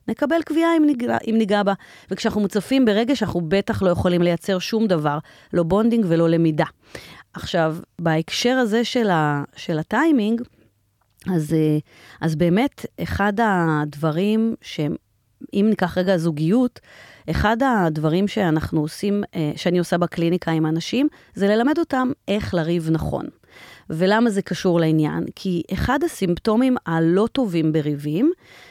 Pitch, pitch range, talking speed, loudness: 185 Hz, 165-225 Hz, 125 wpm, -21 LUFS